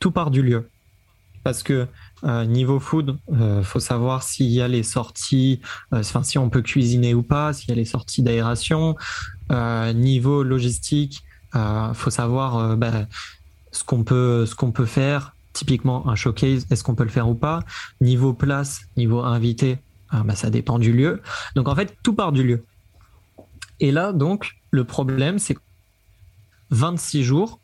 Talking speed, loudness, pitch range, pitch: 180 wpm, -21 LUFS, 115-135 Hz, 125 Hz